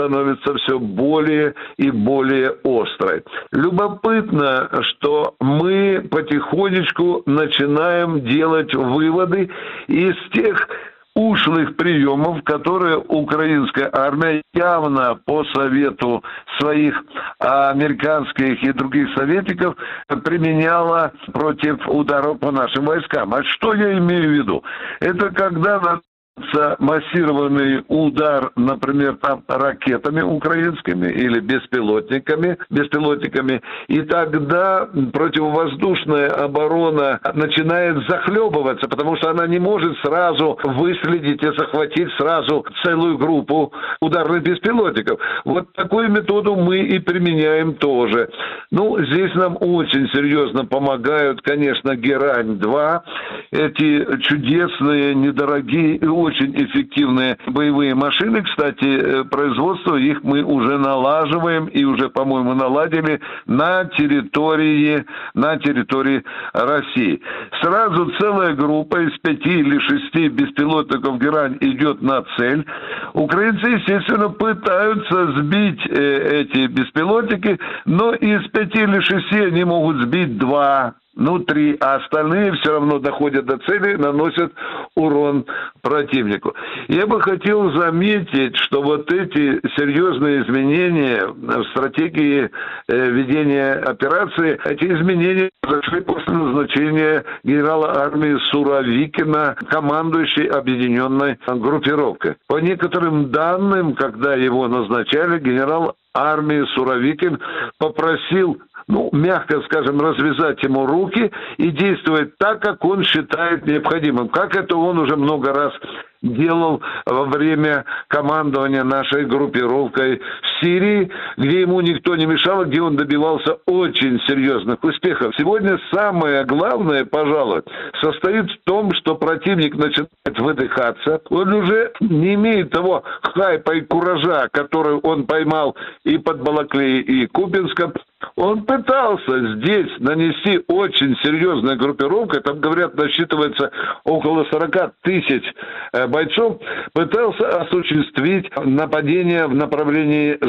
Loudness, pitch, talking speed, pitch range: -17 LUFS, 155 Hz, 105 wpm, 140-180 Hz